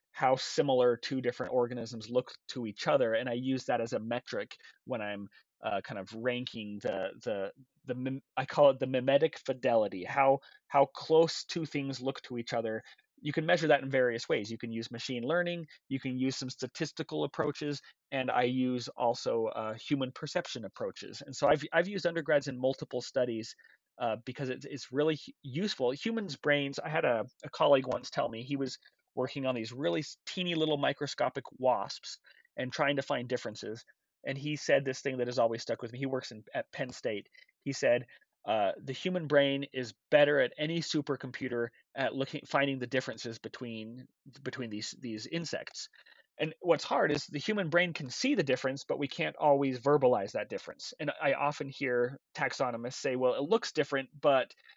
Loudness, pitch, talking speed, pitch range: -32 LUFS, 135 Hz, 190 wpm, 125-150 Hz